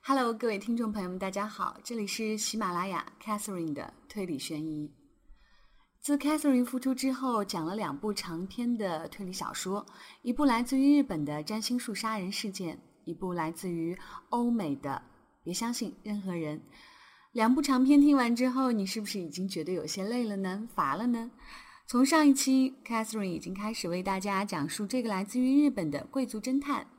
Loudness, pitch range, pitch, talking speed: -31 LUFS, 185-250 Hz, 215 Hz, 320 characters per minute